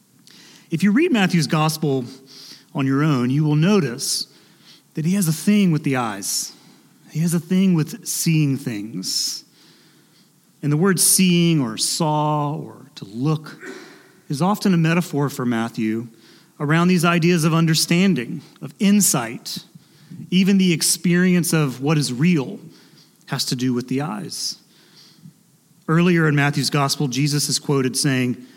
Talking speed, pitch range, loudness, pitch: 145 wpm, 140-180 Hz, -19 LUFS, 160 Hz